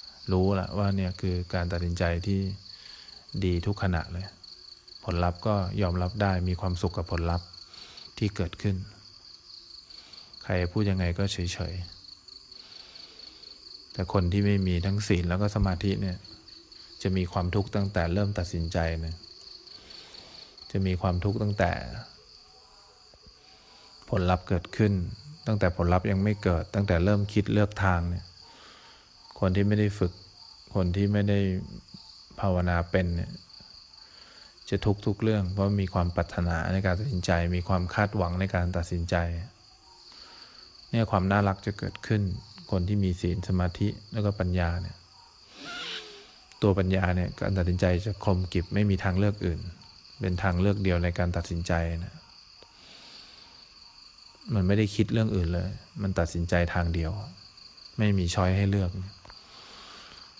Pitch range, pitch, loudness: 90-100 Hz, 95 Hz, -28 LUFS